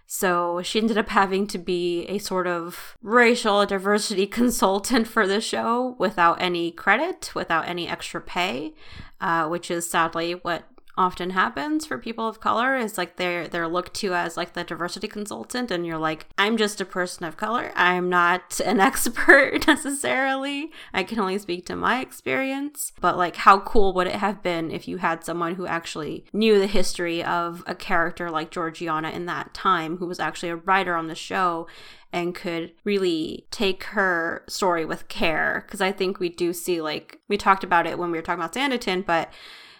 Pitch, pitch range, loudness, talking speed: 180 Hz, 175-215 Hz, -23 LUFS, 190 wpm